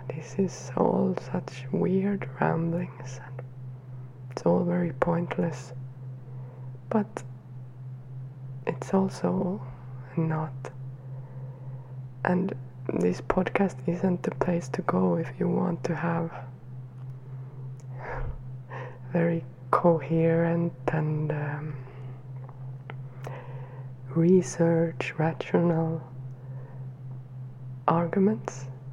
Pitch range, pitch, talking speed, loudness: 130-165 Hz, 130 Hz, 75 wpm, -28 LUFS